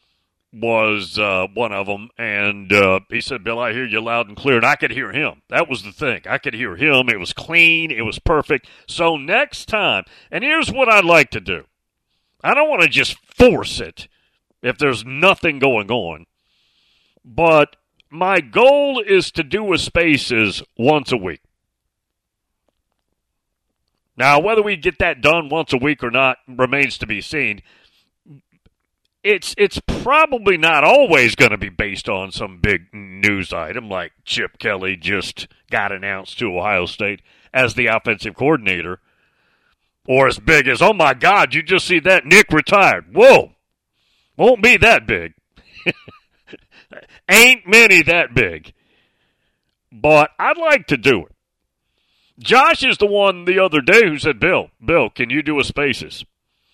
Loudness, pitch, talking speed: -15 LUFS, 140 Hz, 160 wpm